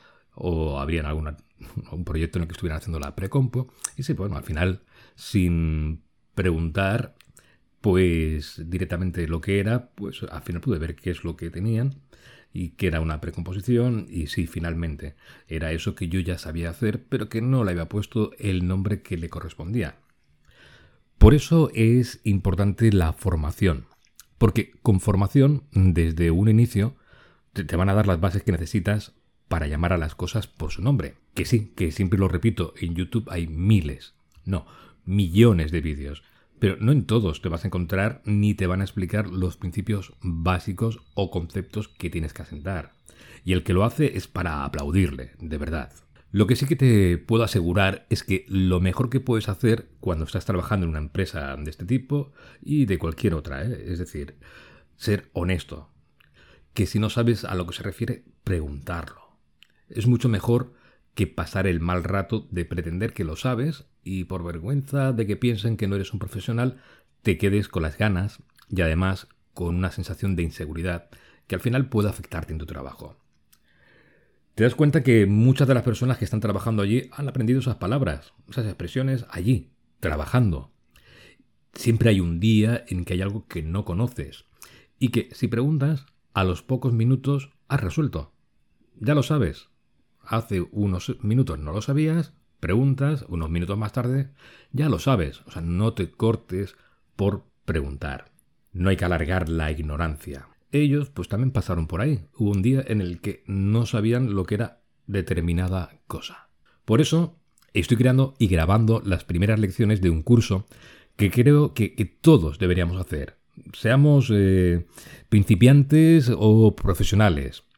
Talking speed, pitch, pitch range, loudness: 170 wpm, 100 Hz, 85-115 Hz, -24 LUFS